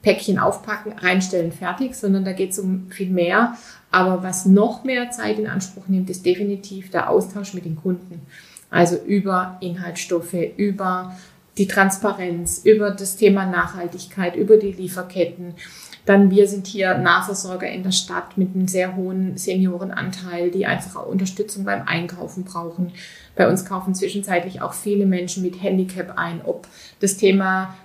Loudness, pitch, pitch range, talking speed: -21 LUFS, 185 Hz, 180-200 Hz, 155 wpm